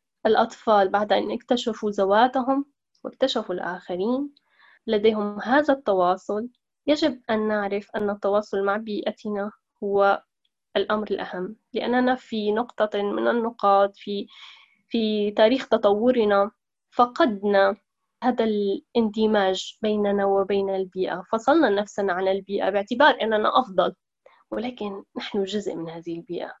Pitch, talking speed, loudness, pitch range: 210 Hz, 110 wpm, -23 LUFS, 200-235 Hz